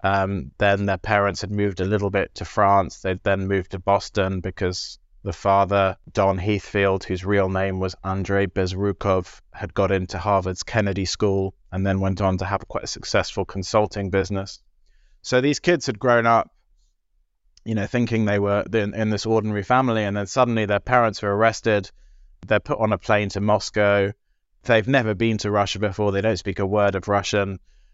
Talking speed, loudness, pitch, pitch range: 185 wpm, -22 LUFS, 100 Hz, 95-105 Hz